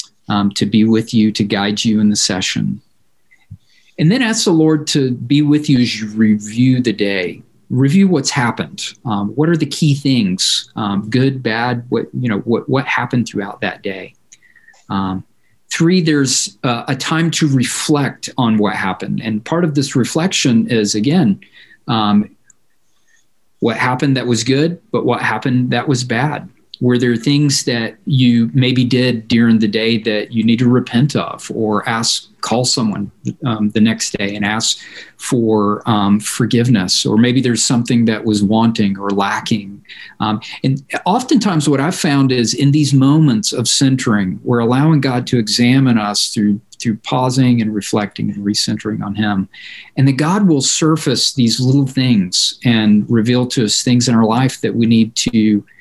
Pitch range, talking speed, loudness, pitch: 110-135 Hz, 170 wpm, -15 LUFS, 120 Hz